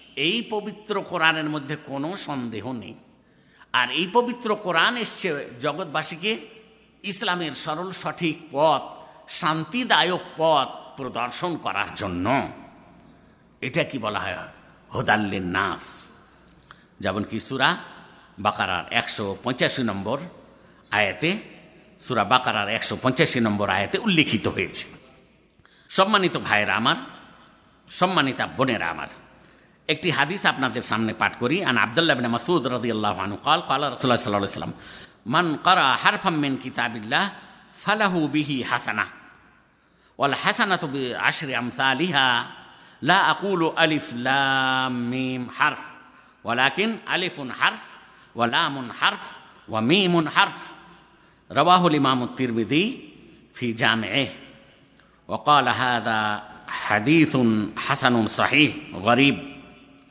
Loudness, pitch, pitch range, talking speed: -23 LUFS, 140 Hz, 120-175 Hz, 105 wpm